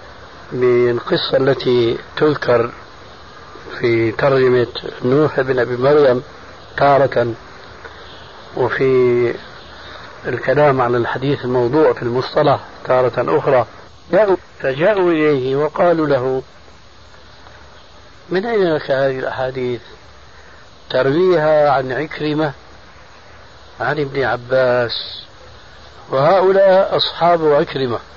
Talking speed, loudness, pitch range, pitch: 80 wpm, -16 LUFS, 120-150 Hz, 130 Hz